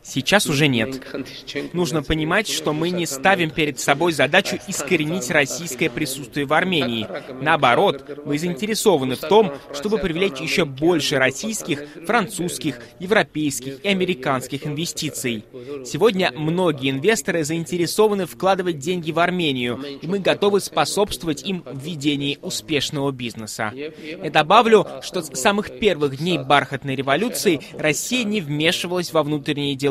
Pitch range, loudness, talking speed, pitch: 140-185 Hz, -20 LUFS, 130 wpm, 155 Hz